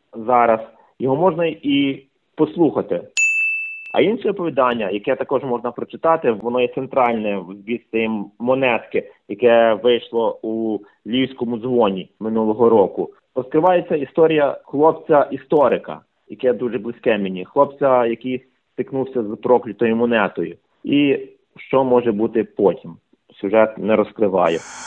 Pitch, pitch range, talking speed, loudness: 125 Hz, 115-140 Hz, 110 wpm, -19 LUFS